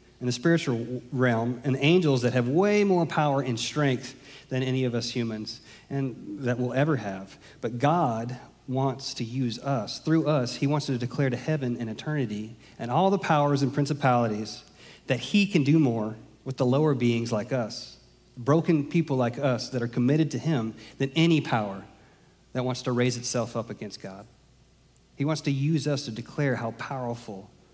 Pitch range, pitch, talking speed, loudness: 120-145 Hz, 130 Hz, 185 wpm, -27 LUFS